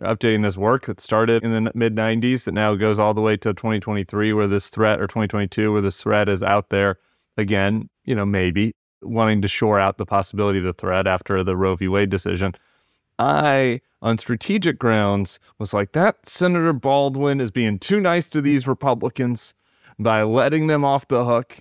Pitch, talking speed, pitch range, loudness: 110 Hz, 190 wpm, 100-120 Hz, -20 LUFS